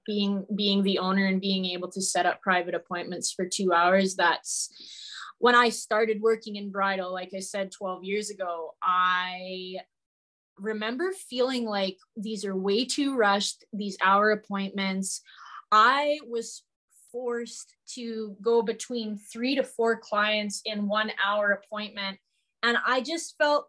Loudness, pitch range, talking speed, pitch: -27 LUFS, 190-230 Hz, 145 wpm, 205 Hz